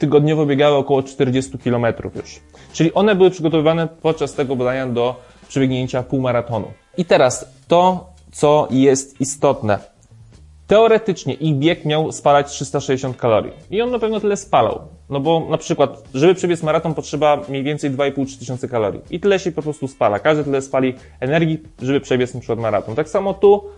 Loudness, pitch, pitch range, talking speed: -18 LUFS, 140 Hz, 130-160 Hz, 165 wpm